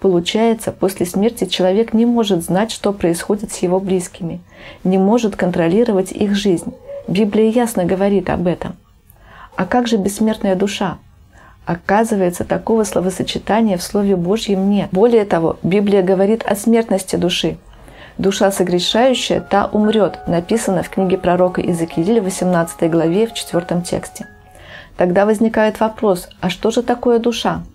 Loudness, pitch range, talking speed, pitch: -16 LUFS, 180-220 Hz, 135 wpm, 195 Hz